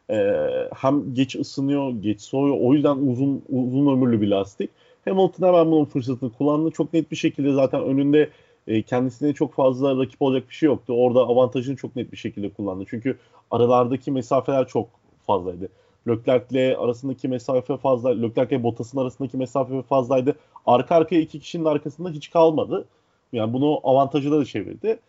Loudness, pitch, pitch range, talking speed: -22 LUFS, 135 Hz, 125-150 Hz, 160 wpm